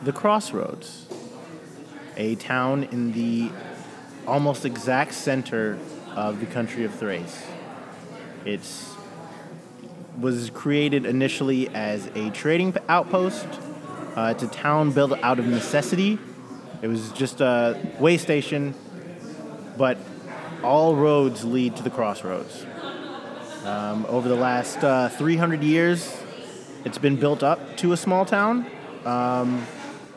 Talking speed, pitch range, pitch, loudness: 115 wpm, 120-150 Hz, 135 Hz, -24 LUFS